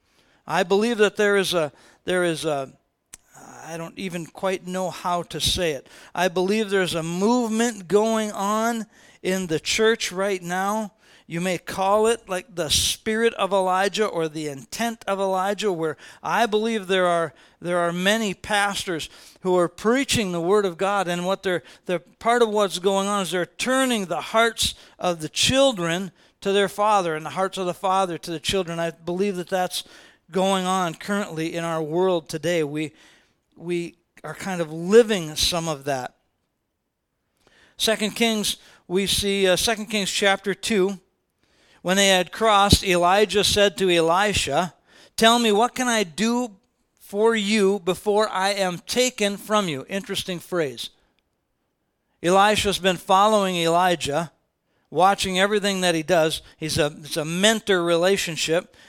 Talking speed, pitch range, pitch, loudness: 160 wpm, 175-210 Hz, 190 Hz, -22 LUFS